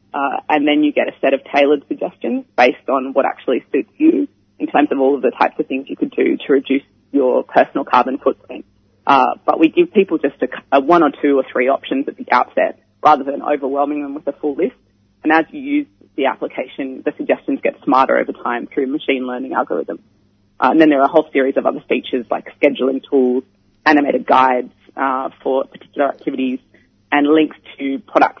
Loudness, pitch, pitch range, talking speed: -17 LUFS, 140 Hz, 130-155 Hz, 210 wpm